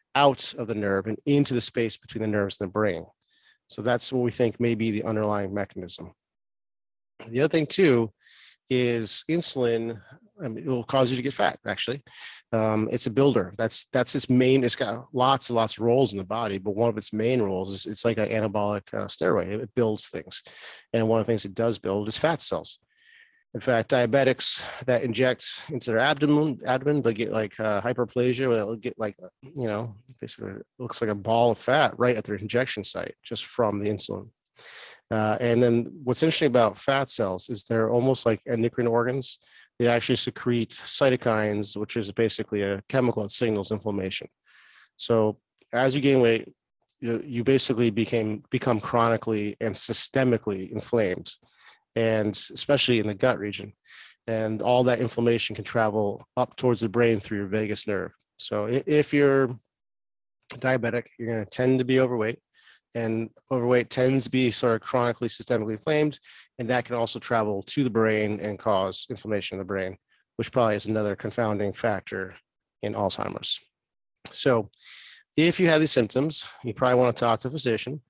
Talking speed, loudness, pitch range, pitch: 180 wpm, -25 LUFS, 110-130 Hz, 115 Hz